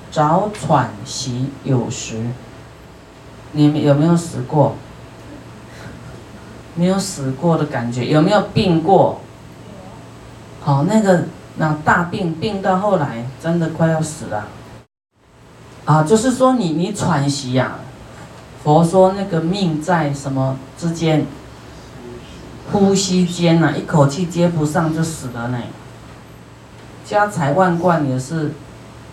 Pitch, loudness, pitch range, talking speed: 155 Hz, -17 LUFS, 135-175 Hz, 170 characters per minute